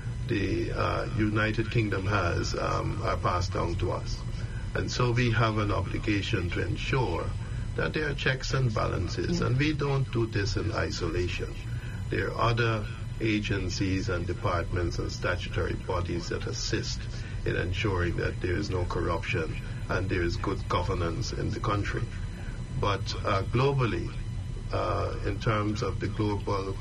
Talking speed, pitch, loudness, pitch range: 150 wpm, 110 Hz, -30 LUFS, 100-115 Hz